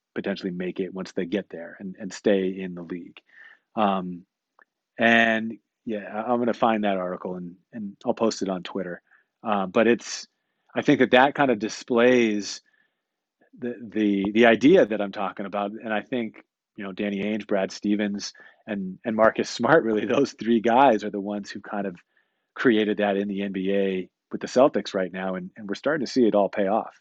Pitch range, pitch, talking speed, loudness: 95-110 Hz, 105 Hz, 200 wpm, -24 LUFS